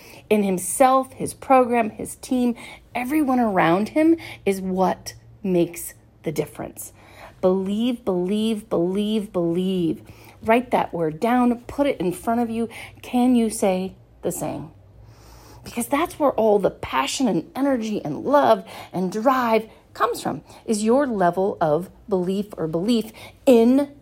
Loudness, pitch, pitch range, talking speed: -22 LUFS, 215 Hz, 175-245 Hz, 135 wpm